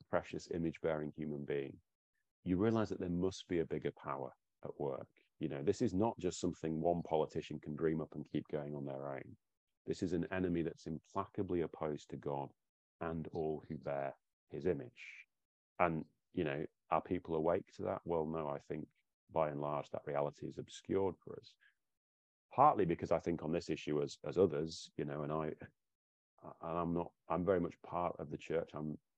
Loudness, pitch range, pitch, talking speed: -40 LUFS, 75-85 Hz, 80 Hz, 195 wpm